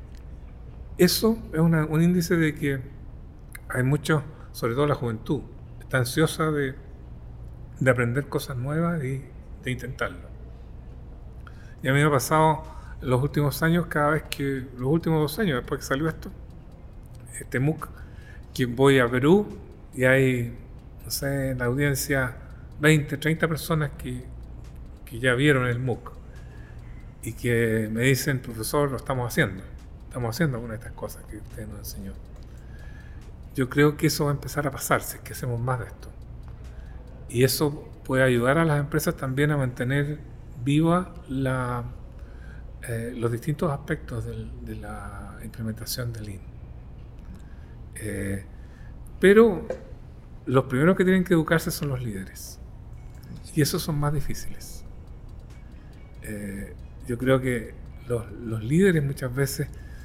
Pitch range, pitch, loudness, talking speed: 110-150 Hz, 130 Hz, -25 LUFS, 145 wpm